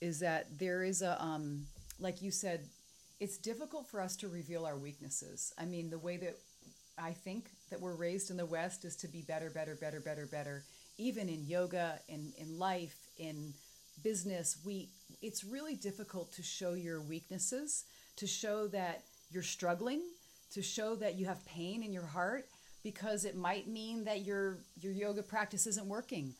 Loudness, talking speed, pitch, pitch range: -41 LUFS, 180 wpm, 180 Hz, 165-205 Hz